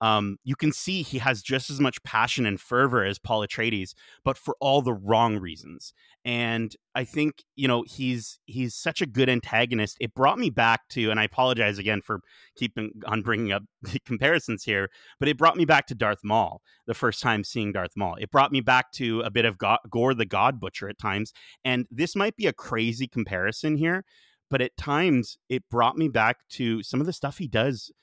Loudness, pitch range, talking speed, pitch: -25 LUFS, 110-135 Hz, 215 wpm, 120 Hz